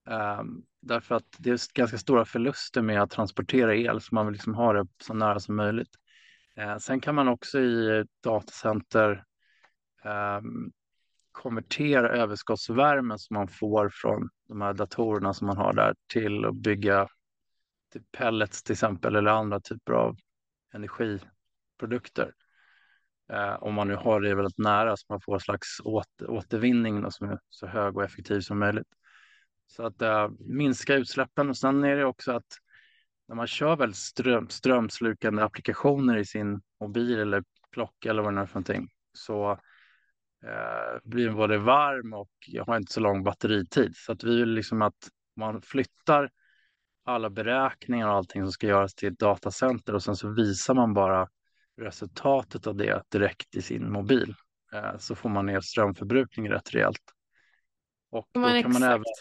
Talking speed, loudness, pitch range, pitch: 165 wpm, -27 LUFS, 100-120 Hz, 110 Hz